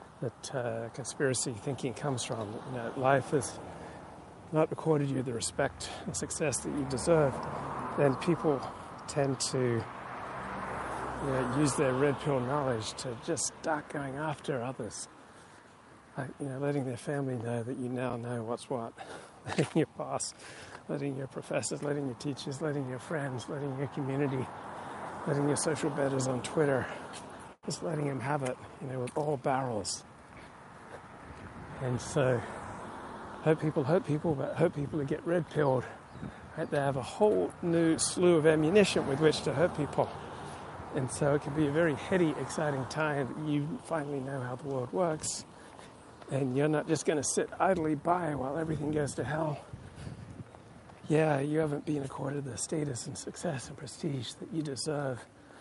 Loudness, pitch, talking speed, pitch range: -32 LUFS, 145 Hz, 165 wpm, 130-155 Hz